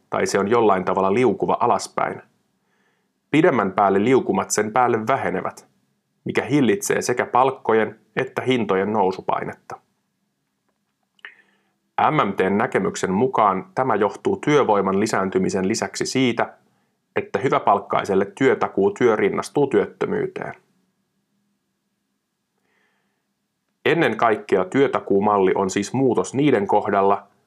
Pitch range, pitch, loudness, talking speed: 100-130 Hz, 110 Hz, -20 LUFS, 90 wpm